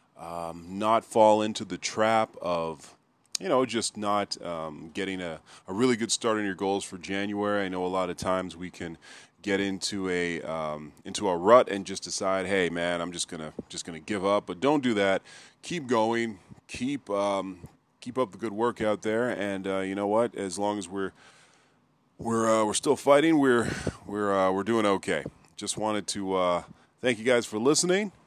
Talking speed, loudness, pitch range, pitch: 205 wpm, -27 LUFS, 95-110 Hz, 100 Hz